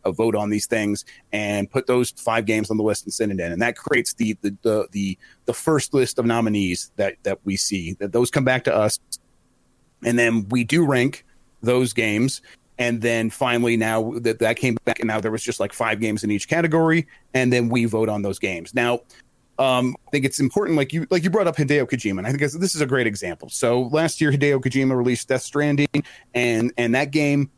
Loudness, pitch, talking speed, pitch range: -21 LUFS, 120 Hz, 230 wpm, 110-135 Hz